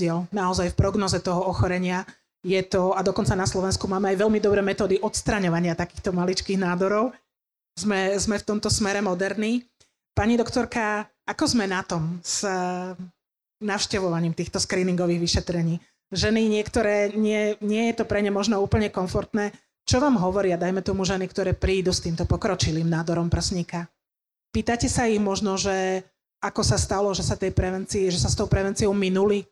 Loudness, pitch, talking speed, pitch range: -24 LUFS, 195 Hz, 160 wpm, 180-210 Hz